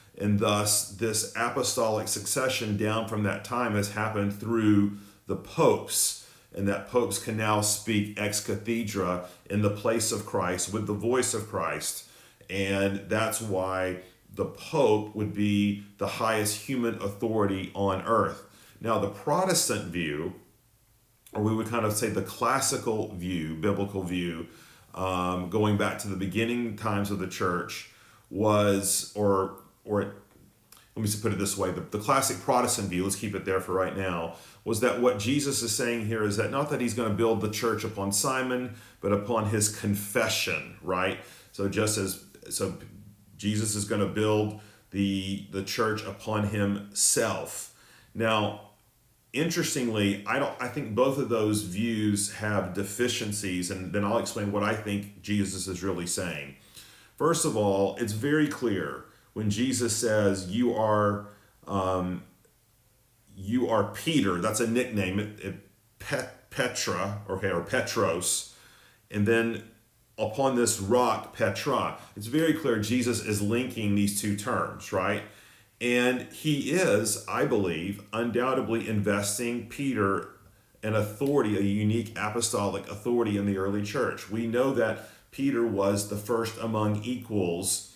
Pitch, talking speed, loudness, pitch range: 105 Hz, 150 wpm, -28 LUFS, 100-115 Hz